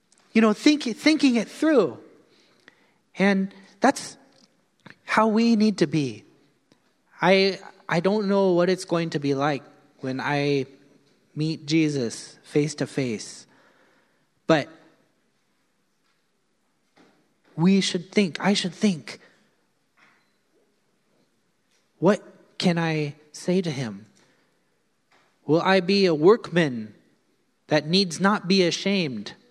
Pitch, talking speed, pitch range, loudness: 175 Hz, 110 wpm, 150-195 Hz, -23 LUFS